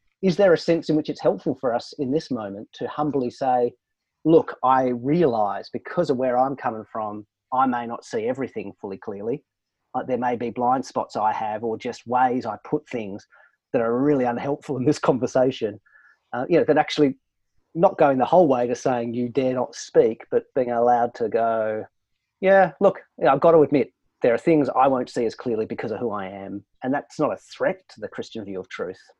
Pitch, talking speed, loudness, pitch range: 125 Hz, 220 wpm, -23 LUFS, 115-145 Hz